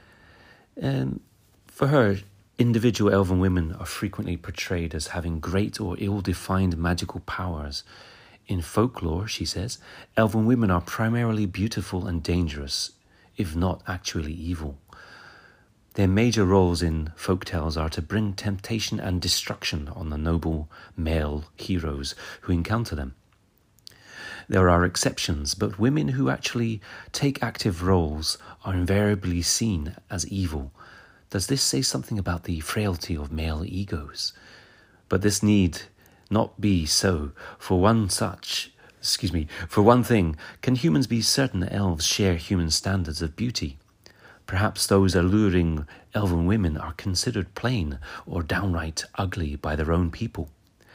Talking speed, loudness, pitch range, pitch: 135 wpm, -25 LUFS, 85-105 Hz, 95 Hz